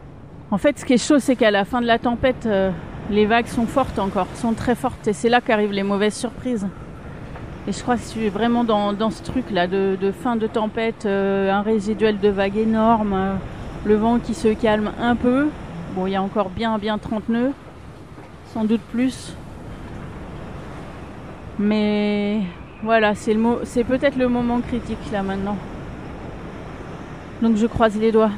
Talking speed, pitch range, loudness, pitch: 180 wpm, 205-240 Hz, -21 LUFS, 220 Hz